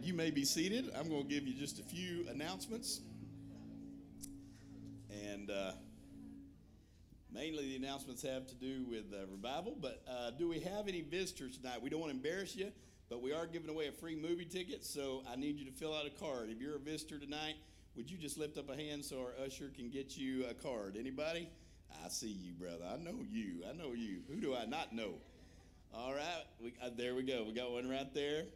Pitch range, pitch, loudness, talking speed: 105-155 Hz, 135 Hz, -44 LUFS, 220 wpm